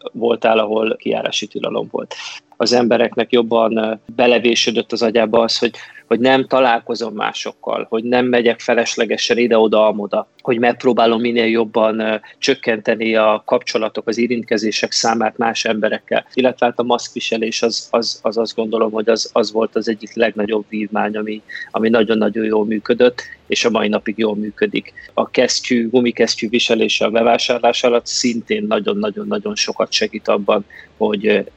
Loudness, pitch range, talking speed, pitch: -17 LUFS, 110-120 Hz, 145 wpm, 115 Hz